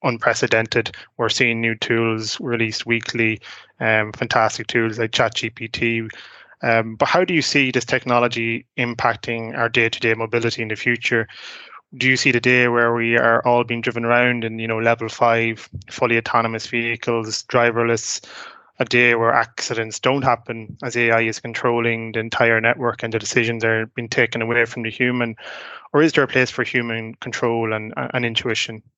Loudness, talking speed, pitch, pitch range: -19 LUFS, 170 wpm, 115 Hz, 115-120 Hz